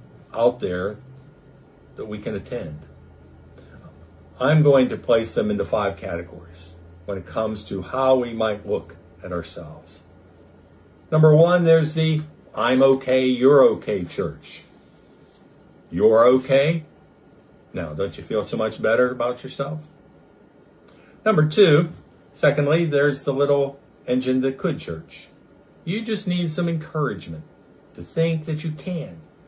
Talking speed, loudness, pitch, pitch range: 130 wpm, -21 LUFS, 135 Hz, 100-155 Hz